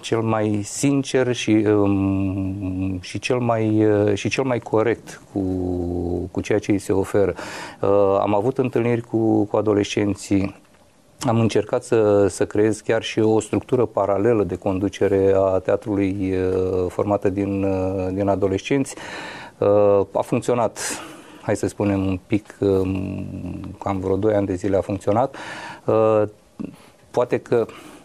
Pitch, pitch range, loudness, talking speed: 100 Hz, 95-110 Hz, -21 LUFS, 125 wpm